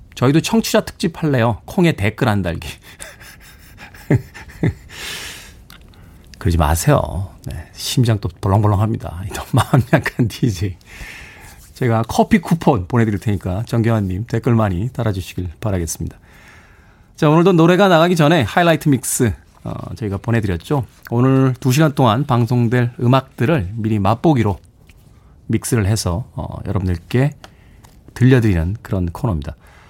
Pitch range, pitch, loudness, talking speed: 95-130 Hz, 110 Hz, -17 LUFS, 285 characters per minute